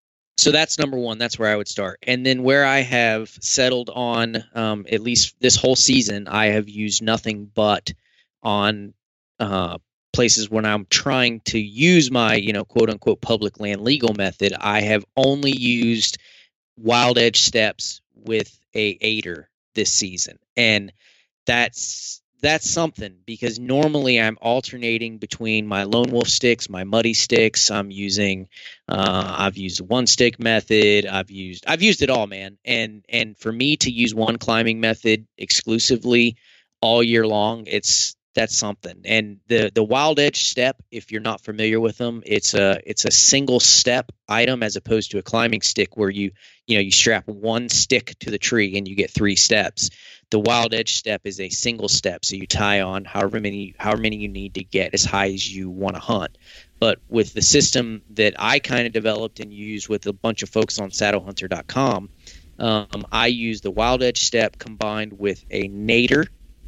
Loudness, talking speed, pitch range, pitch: -19 LUFS, 180 wpm, 100-120 Hz, 110 Hz